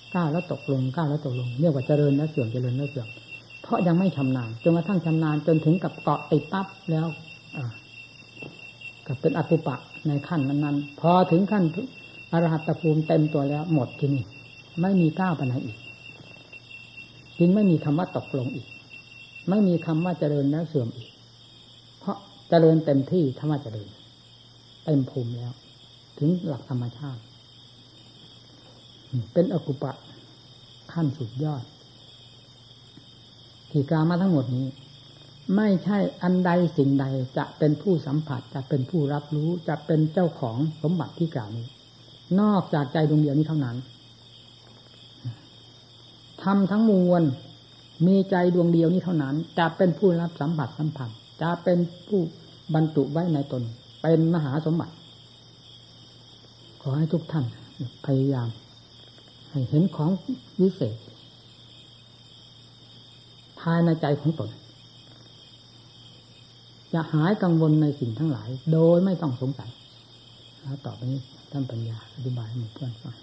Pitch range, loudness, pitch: 125-160 Hz, -25 LUFS, 140 Hz